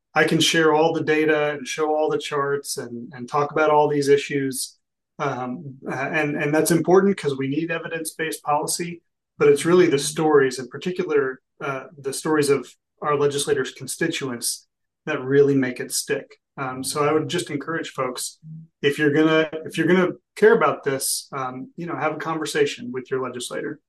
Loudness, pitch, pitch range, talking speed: -22 LUFS, 150 Hz, 140-160 Hz, 180 wpm